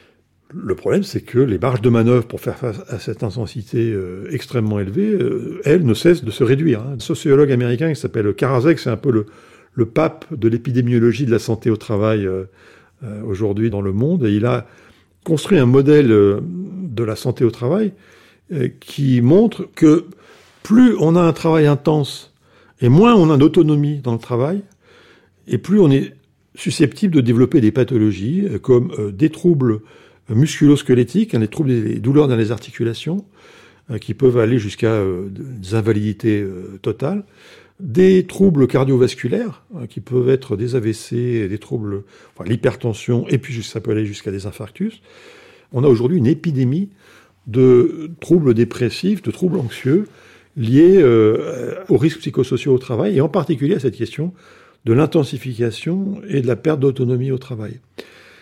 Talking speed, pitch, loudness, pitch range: 155 wpm, 125 Hz, -17 LUFS, 115-160 Hz